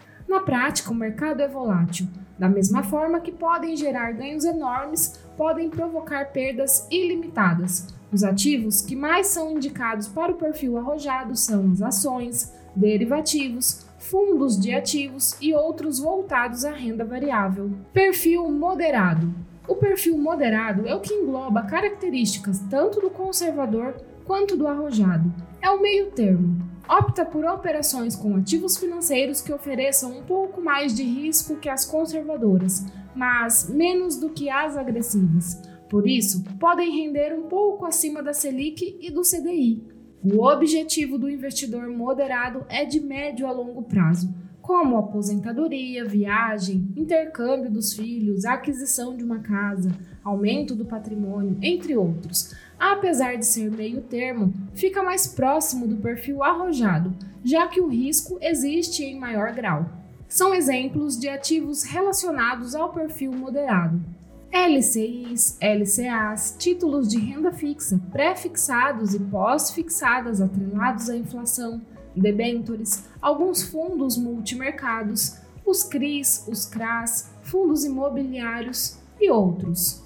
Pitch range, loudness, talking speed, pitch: 215-315 Hz, -23 LUFS, 130 wpm, 260 Hz